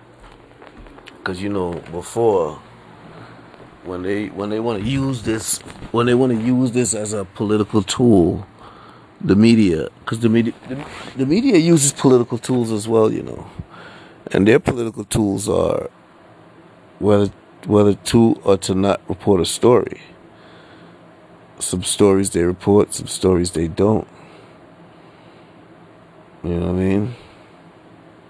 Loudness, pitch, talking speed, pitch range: -18 LUFS, 105 Hz, 135 wpm, 95-115 Hz